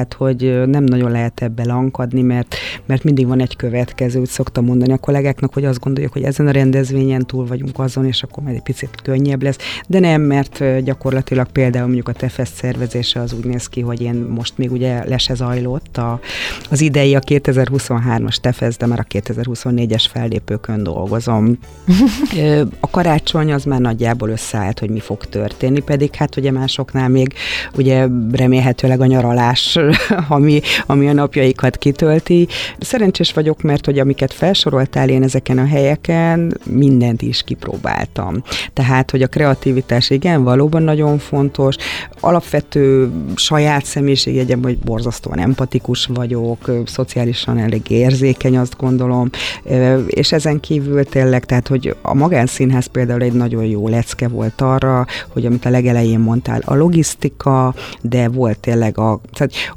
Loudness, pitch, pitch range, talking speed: -15 LUFS, 130 Hz, 120-140 Hz, 150 wpm